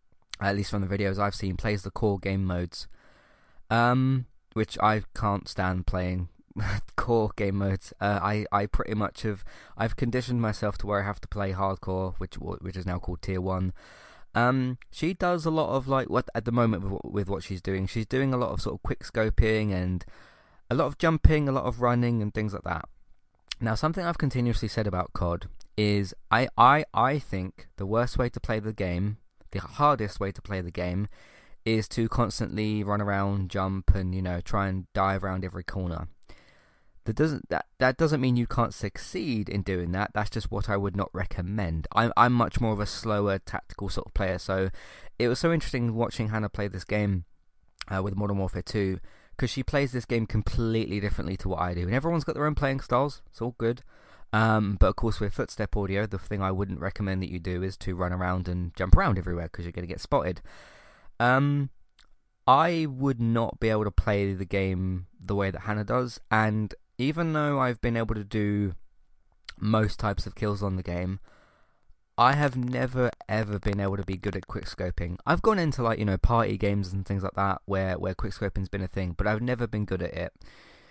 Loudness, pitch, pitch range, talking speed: -28 LUFS, 100 Hz, 95-115 Hz, 210 wpm